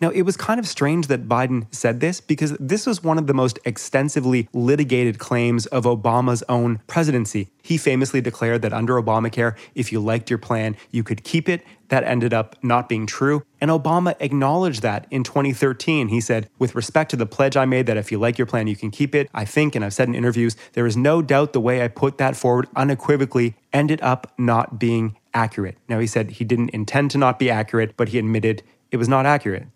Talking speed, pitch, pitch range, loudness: 220 wpm, 125 Hz, 115-140 Hz, -20 LUFS